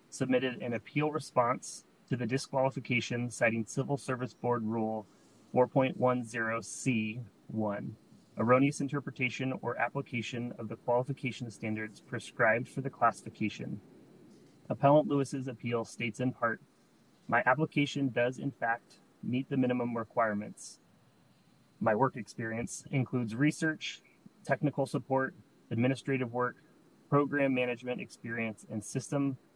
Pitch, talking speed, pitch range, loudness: 125 Hz, 110 wpm, 115-135 Hz, -33 LUFS